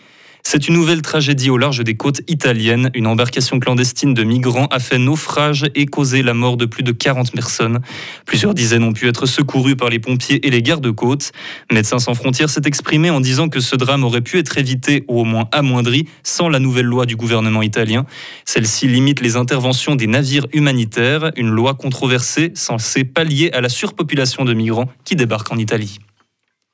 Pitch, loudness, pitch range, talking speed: 130 Hz, -15 LUFS, 120-145 Hz, 190 wpm